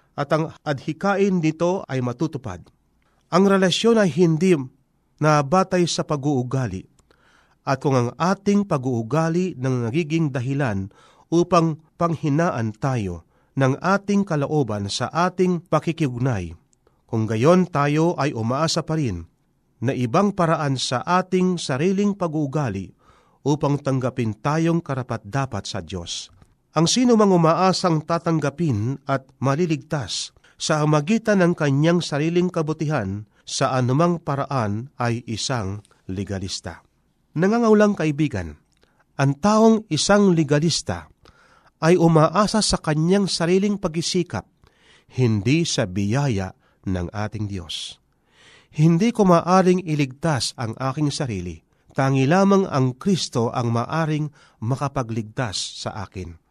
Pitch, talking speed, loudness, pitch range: 150 Hz, 110 wpm, -21 LUFS, 125-170 Hz